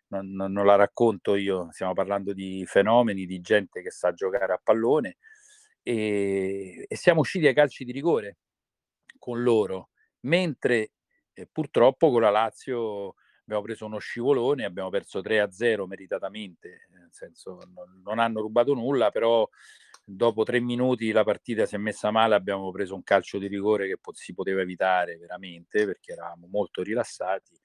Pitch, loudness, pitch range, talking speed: 110 Hz, -25 LUFS, 95-125 Hz, 160 wpm